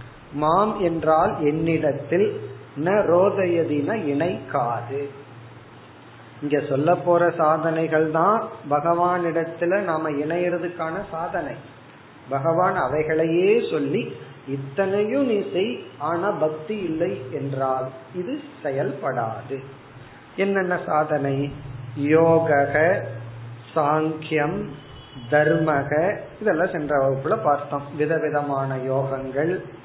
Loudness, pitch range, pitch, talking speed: -22 LUFS, 135-170 Hz, 155 Hz, 80 wpm